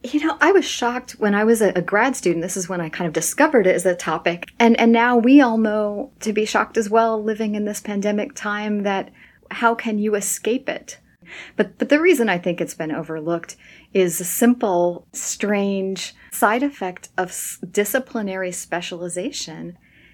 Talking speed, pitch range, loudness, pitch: 185 wpm, 180-230 Hz, -20 LUFS, 210 Hz